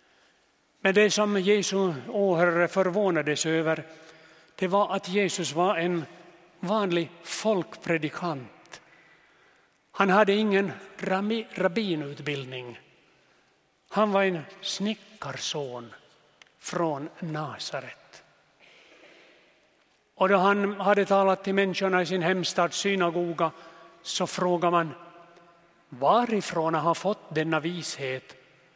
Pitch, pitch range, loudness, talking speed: 180 Hz, 165-195 Hz, -26 LUFS, 90 wpm